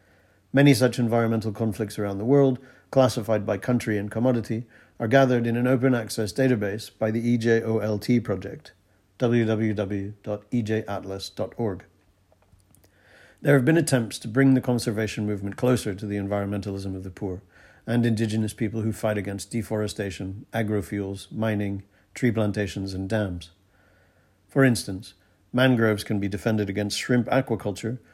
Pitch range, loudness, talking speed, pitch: 100-120 Hz, -25 LUFS, 130 wpm, 110 Hz